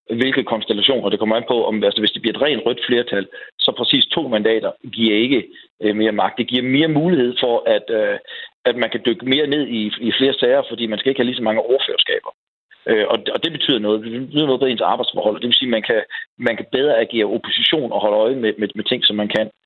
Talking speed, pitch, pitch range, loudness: 240 wpm, 125 Hz, 110-150 Hz, -18 LUFS